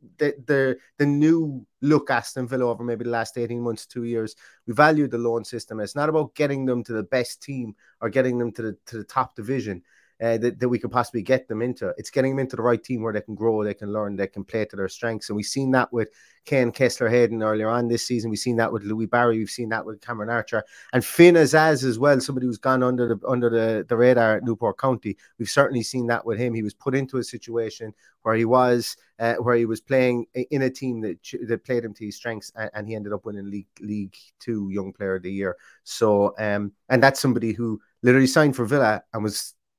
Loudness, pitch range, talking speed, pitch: -23 LUFS, 110-130 Hz, 245 wpm, 120 Hz